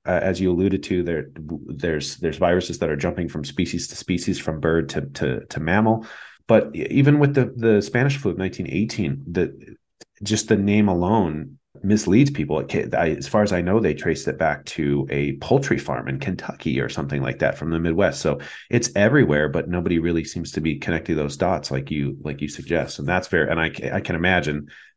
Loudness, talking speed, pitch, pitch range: -22 LUFS, 205 wpm, 90 Hz, 75-105 Hz